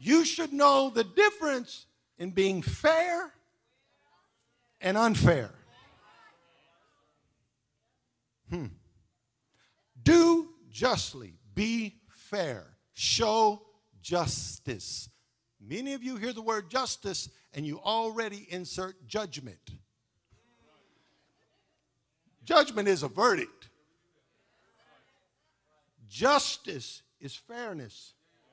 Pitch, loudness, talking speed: 210 Hz, -28 LUFS, 75 wpm